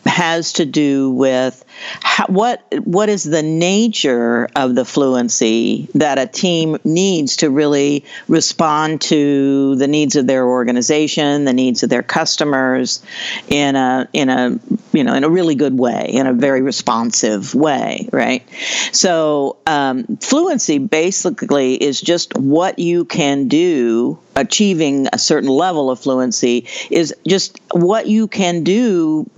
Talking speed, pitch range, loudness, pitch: 145 wpm, 130-180 Hz, -15 LUFS, 150 Hz